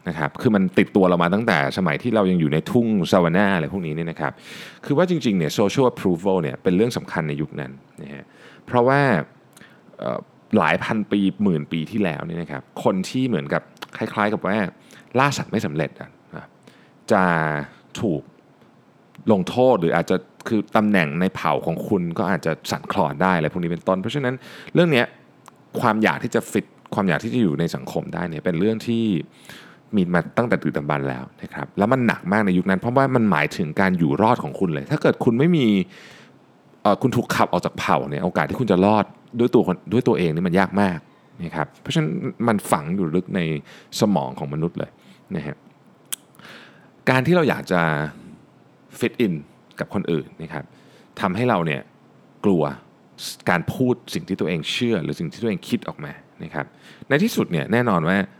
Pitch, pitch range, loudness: 95 Hz, 80-115 Hz, -21 LUFS